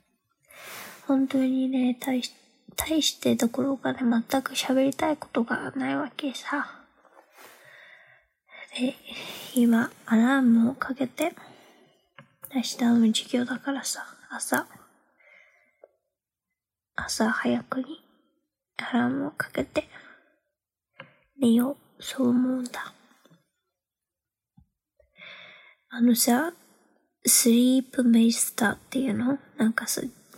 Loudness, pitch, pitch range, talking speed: -25 LUFS, 260 Hz, 240-275 Hz, 180 characters per minute